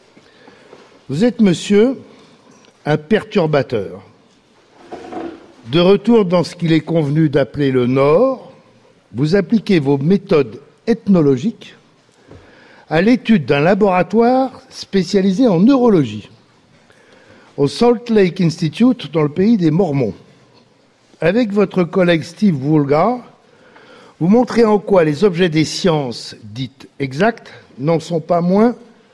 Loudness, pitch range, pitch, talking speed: -15 LUFS, 155-230 Hz, 195 Hz, 115 wpm